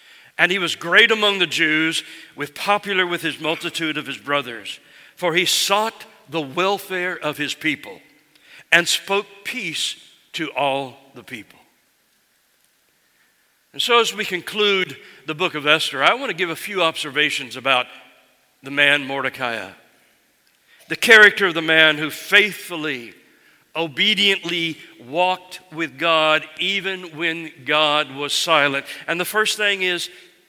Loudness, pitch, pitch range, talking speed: -18 LUFS, 165 Hz, 150-185 Hz, 140 wpm